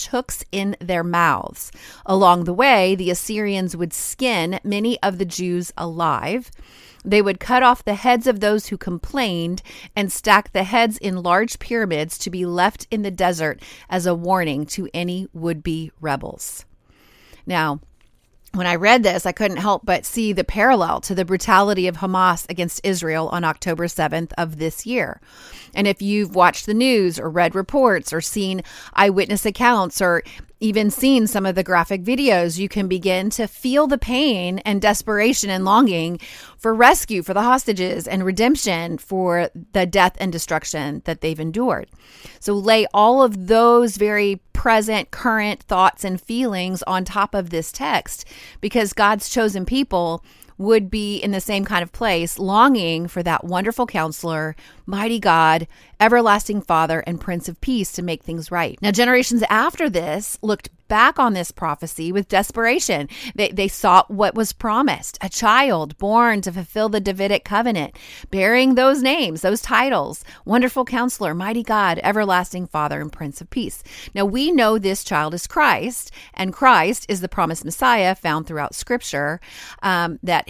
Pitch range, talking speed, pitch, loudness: 175-225 Hz, 165 wpm, 195 Hz, -19 LUFS